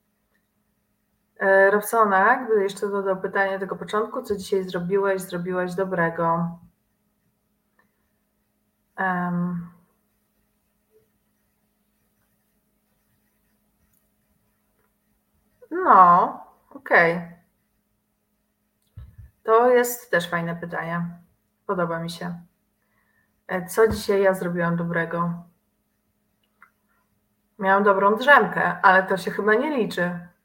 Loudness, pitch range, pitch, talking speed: -21 LUFS, 175-210 Hz, 190 Hz, 80 wpm